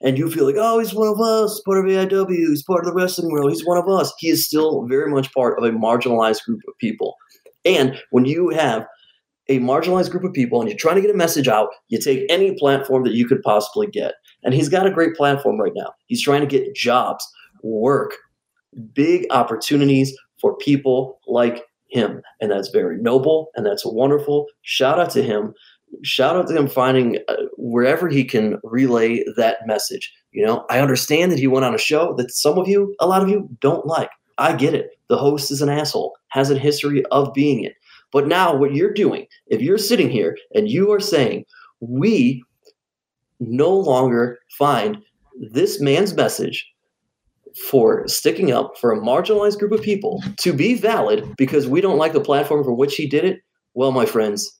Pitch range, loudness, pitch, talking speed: 135-210 Hz, -18 LUFS, 150 Hz, 200 wpm